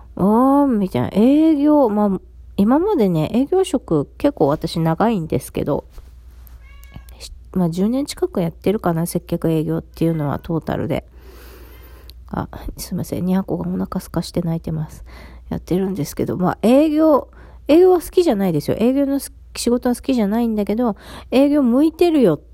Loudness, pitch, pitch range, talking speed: -18 LUFS, 190 Hz, 160-260 Hz, 320 characters per minute